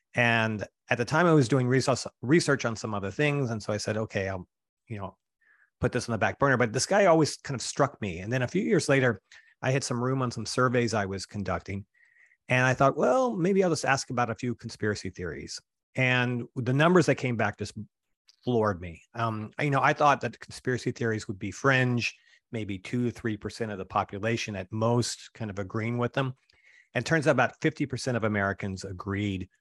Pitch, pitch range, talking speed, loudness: 120 Hz, 105-130 Hz, 220 wpm, -27 LUFS